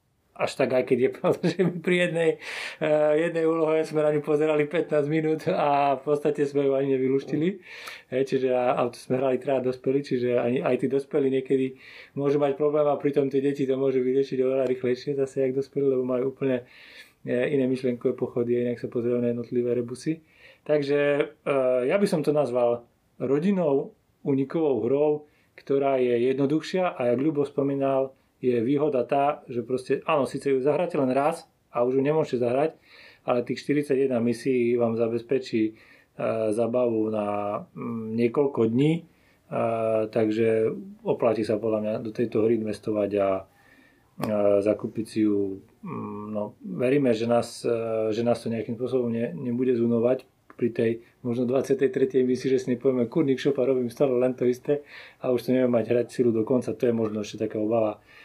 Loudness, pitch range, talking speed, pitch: -25 LUFS, 120-145 Hz, 170 wpm, 130 Hz